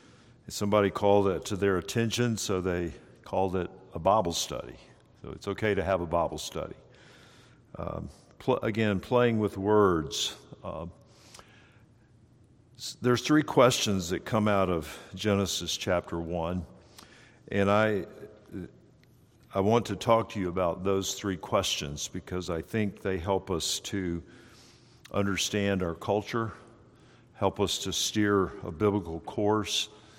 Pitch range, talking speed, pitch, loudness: 95-110 Hz, 135 wpm, 100 Hz, -29 LUFS